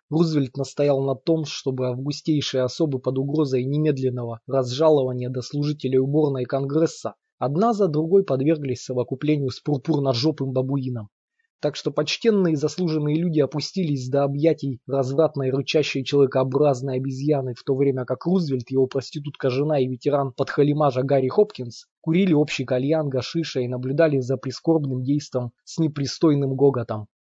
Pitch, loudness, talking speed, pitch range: 140 Hz, -23 LUFS, 130 wpm, 130-155 Hz